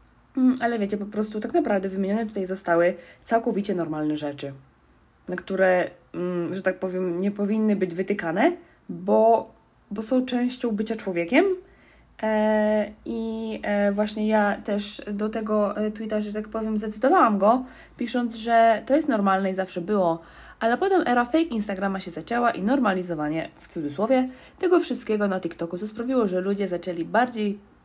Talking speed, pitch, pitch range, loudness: 145 wpm, 210 Hz, 185-235 Hz, -24 LUFS